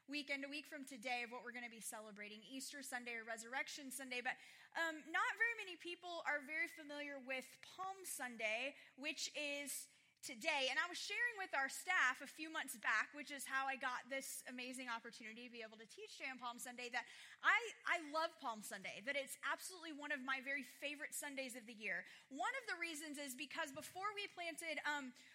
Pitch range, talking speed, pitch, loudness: 250-320 Hz, 210 wpm, 280 Hz, -44 LUFS